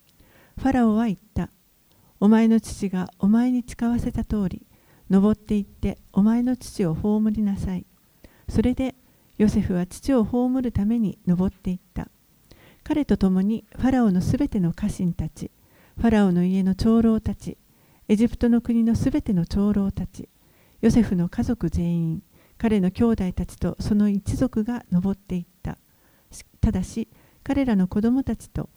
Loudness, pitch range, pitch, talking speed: -23 LUFS, 185-235 Hz, 210 Hz, 290 characters per minute